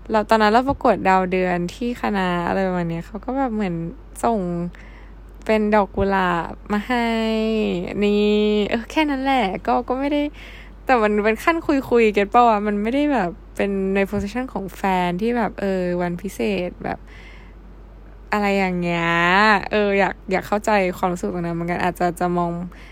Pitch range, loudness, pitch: 180-230 Hz, -20 LUFS, 205 Hz